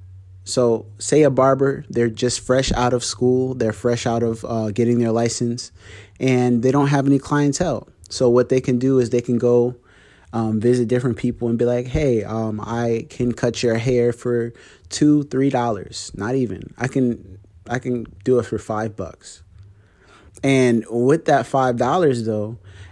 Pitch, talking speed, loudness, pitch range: 120 Hz, 180 wpm, -20 LUFS, 110-125 Hz